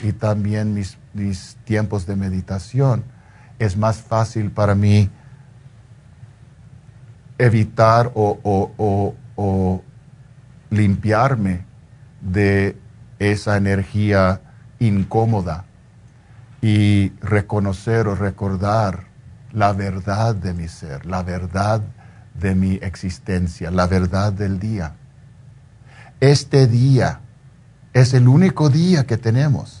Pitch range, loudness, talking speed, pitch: 100-125 Hz, -19 LUFS, 95 wpm, 110 Hz